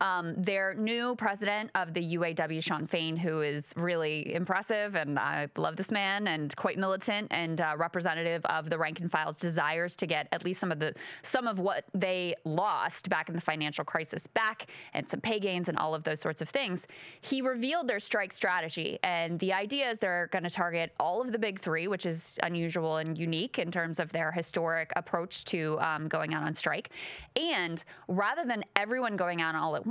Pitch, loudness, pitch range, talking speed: 175 Hz, -32 LUFS, 160-195 Hz, 205 wpm